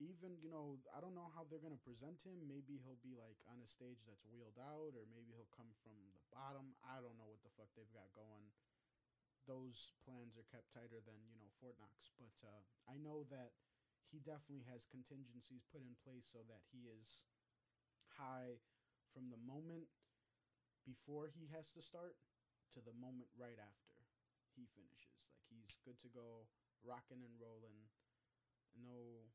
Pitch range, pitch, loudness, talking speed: 115-135 Hz, 125 Hz, -60 LUFS, 180 wpm